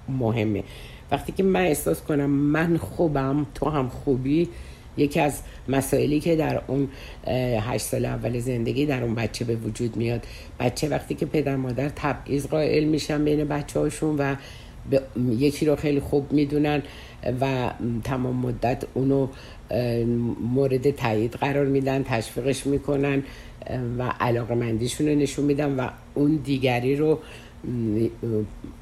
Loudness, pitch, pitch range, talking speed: -25 LUFS, 135 Hz, 120-145 Hz, 135 wpm